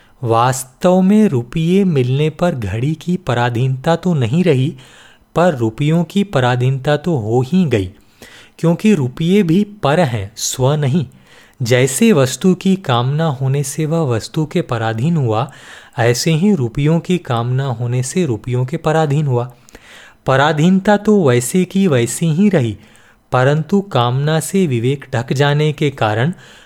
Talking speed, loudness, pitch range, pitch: 140 wpm, -15 LUFS, 120-170 Hz, 145 Hz